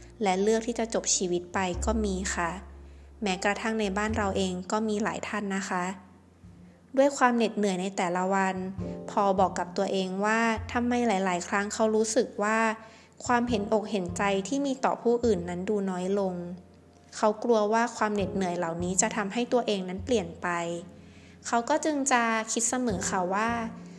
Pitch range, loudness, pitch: 185-225 Hz, -28 LUFS, 205 Hz